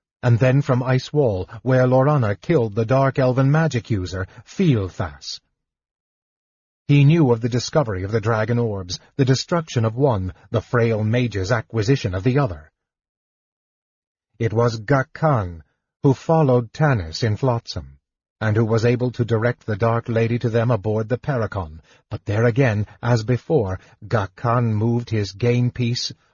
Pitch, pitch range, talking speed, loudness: 120 Hz, 105-130 Hz, 150 wpm, -20 LUFS